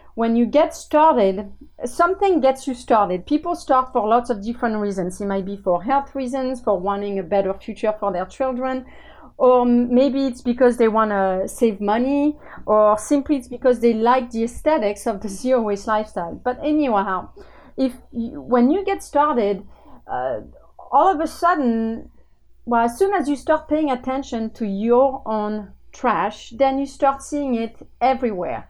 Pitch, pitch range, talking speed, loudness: 245 Hz, 215-275 Hz, 170 wpm, -20 LUFS